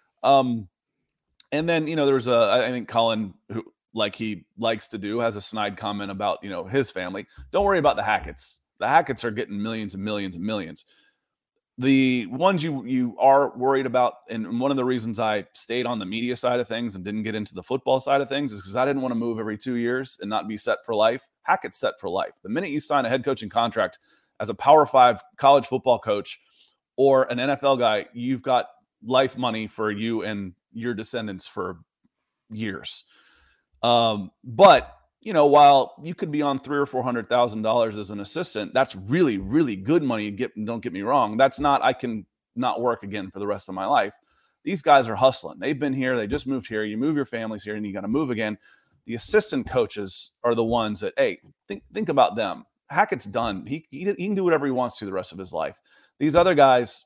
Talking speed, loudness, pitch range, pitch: 220 wpm, -23 LUFS, 105-135 Hz, 120 Hz